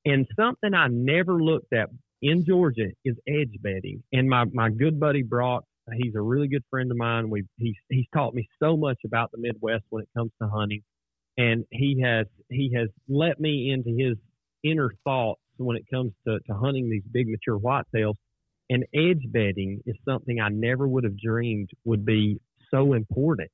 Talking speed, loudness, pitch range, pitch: 190 wpm, -26 LUFS, 110-135 Hz, 120 Hz